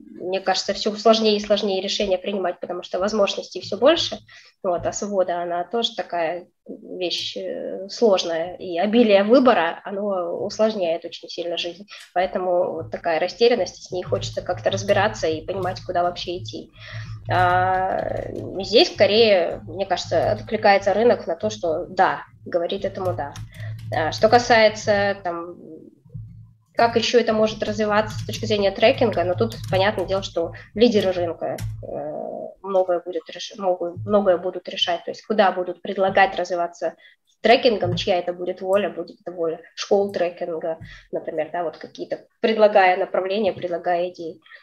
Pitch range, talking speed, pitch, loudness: 170-200 Hz, 145 wpm, 180 Hz, -21 LUFS